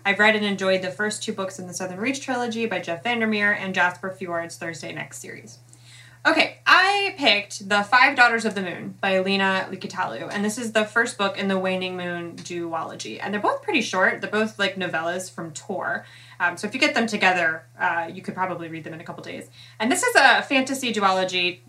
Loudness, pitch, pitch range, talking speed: -22 LUFS, 190 Hz, 175-220 Hz, 220 wpm